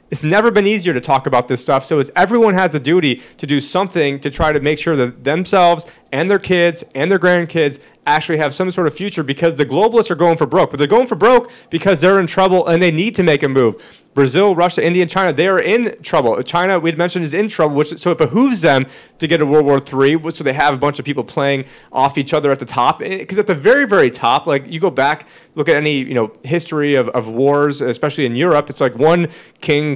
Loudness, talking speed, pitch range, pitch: -15 LUFS, 250 wpm, 145-180 Hz, 160 Hz